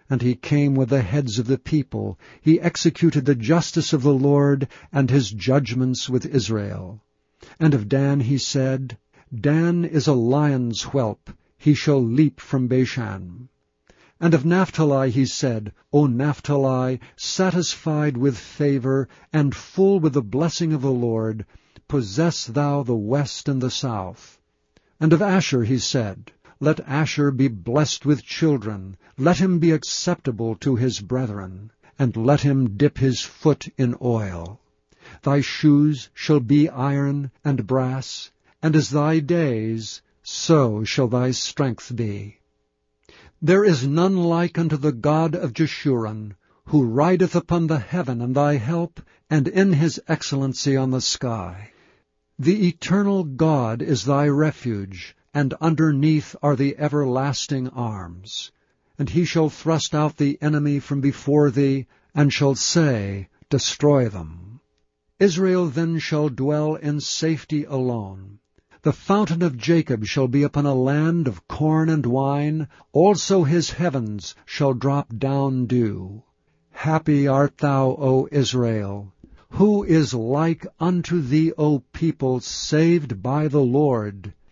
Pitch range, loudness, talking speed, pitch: 125-155 Hz, -21 LUFS, 140 wpm, 140 Hz